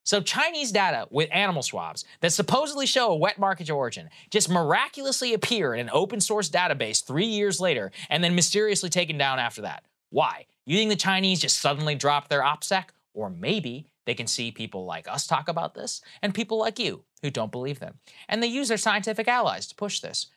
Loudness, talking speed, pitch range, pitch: -25 LUFS, 205 wpm, 145-215 Hz, 185 Hz